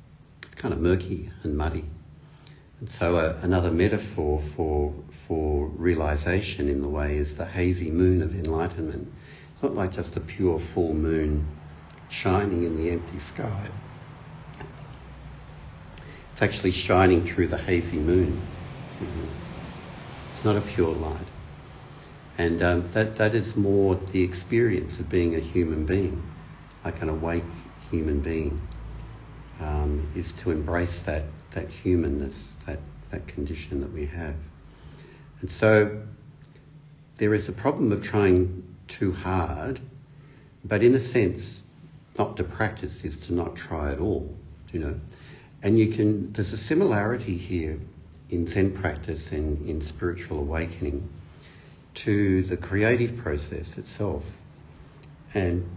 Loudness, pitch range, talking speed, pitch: -26 LUFS, 80-105 Hz, 135 wpm, 90 Hz